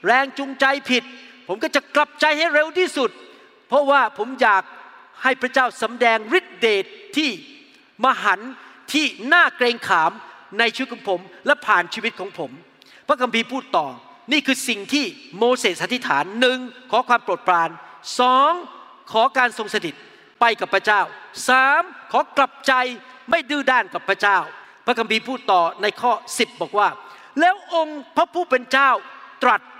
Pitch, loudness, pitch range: 260 Hz, -19 LUFS, 235-300 Hz